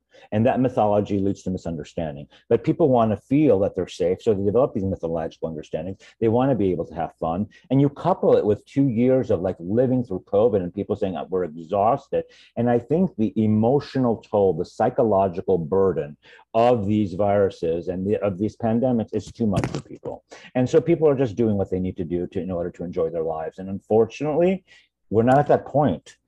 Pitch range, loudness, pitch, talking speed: 95-130 Hz, -22 LUFS, 110 Hz, 210 wpm